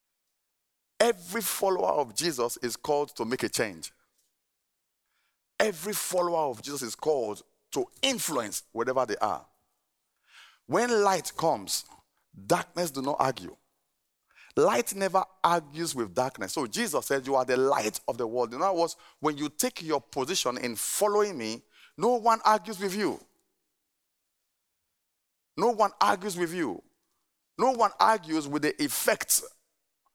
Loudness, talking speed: -28 LUFS, 140 wpm